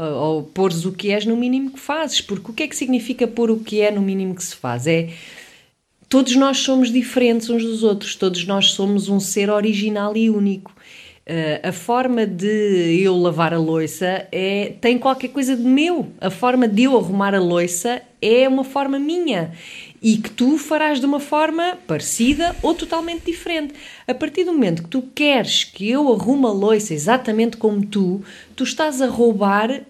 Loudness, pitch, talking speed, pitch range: -18 LUFS, 230 Hz, 190 wpm, 195-265 Hz